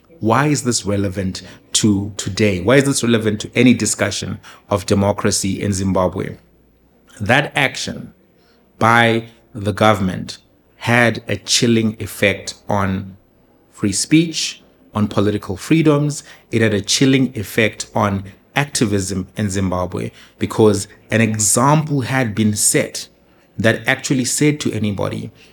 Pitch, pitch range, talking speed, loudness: 105 Hz, 100-120 Hz, 120 wpm, -17 LUFS